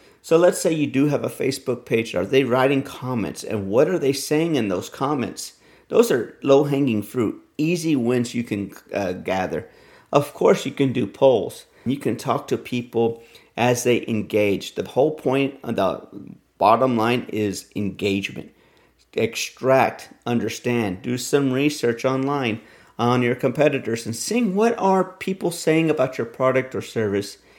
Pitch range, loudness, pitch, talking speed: 115-140 Hz, -22 LUFS, 125 Hz, 160 wpm